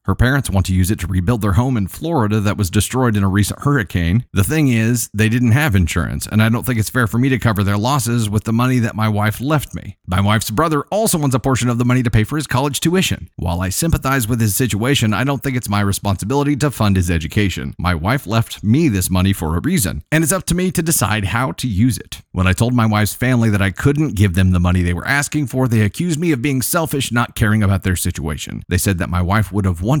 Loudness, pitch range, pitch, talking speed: -17 LUFS, 100-135 Hz, 110 Hz, 270 wpm